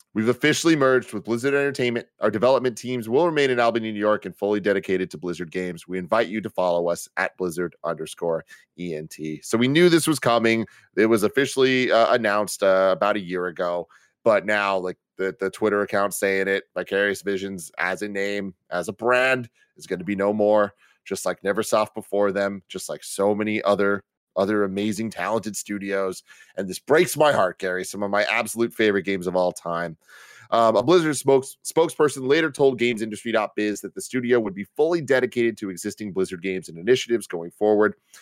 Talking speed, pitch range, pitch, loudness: 190 wpm, 95-120 Hz, 105 Hz, -23 LUFS